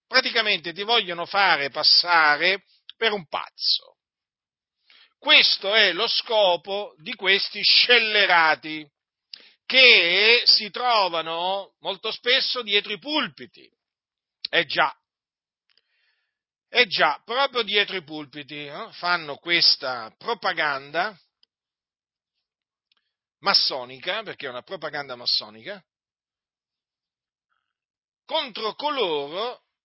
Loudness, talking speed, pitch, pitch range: -20 LUFS, 90 wpm, 200 Hz, 165-245 Hz